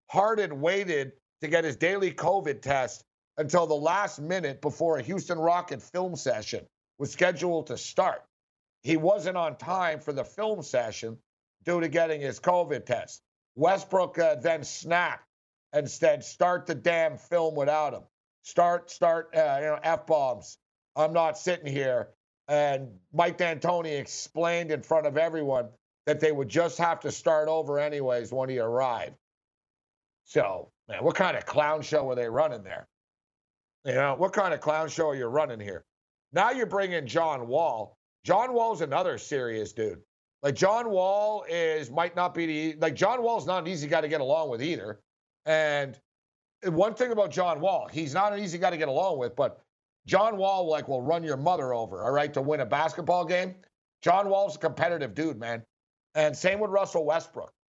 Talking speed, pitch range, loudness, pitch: 180 wpm, 150-180 Hz, -28 LUFS, 165 Hz